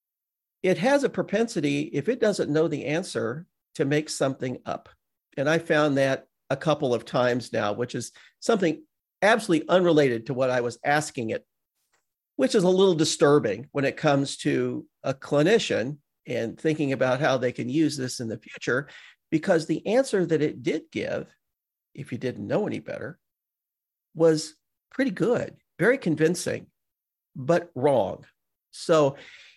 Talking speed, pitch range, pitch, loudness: 155 wpm, 135-175 Hz, 155 Hz, -25 LUFS